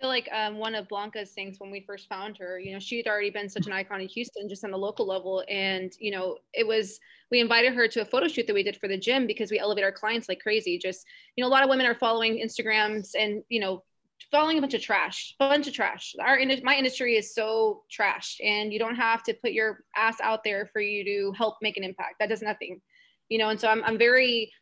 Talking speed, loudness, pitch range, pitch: 260 wpm, -26 LUFS, 200-235 Hz, 220 Hz